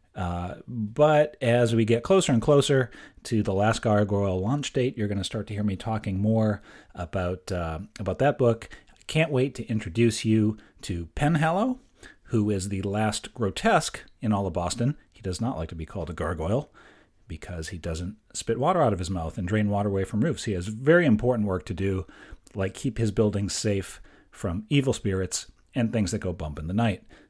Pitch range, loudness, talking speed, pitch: 95-120 Hz, -26 LUFS, 200 wpm, 105 Hz